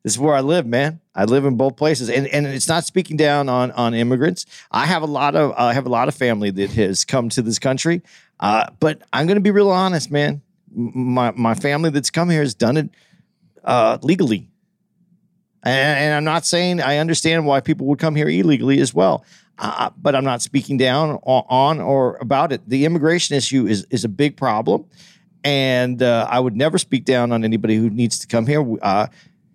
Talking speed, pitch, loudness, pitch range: 215 wpm, 140 Hz, -18 LUFS, 125-160 Hz